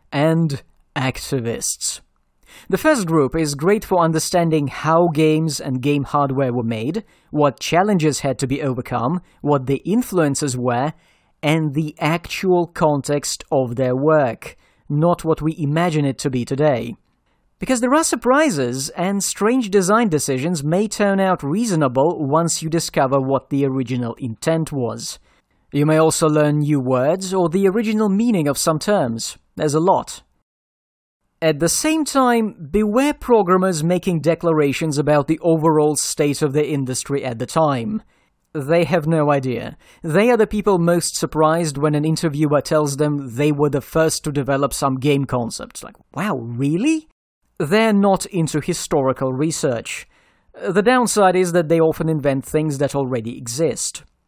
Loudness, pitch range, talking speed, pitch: -19 LUFS, 140-180 Hz, 155 wpm, 155 Hz